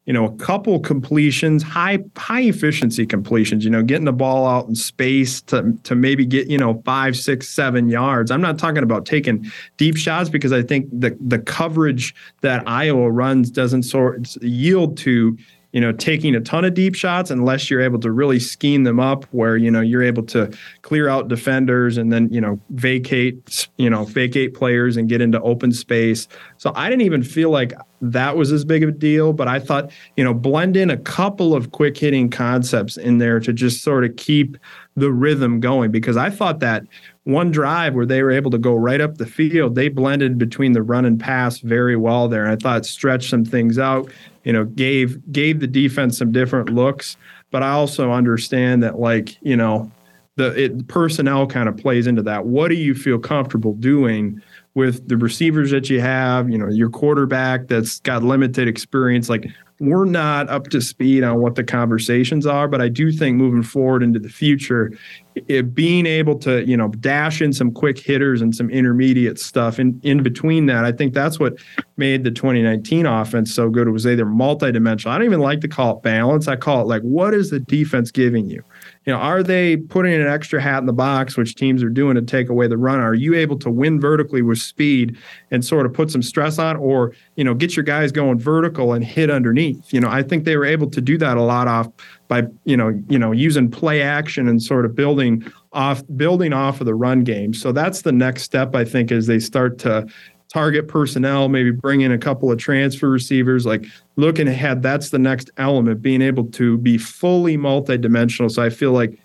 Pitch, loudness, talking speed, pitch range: 130 Hz, -17 LUFS, 215 wpm, 120-145 Hz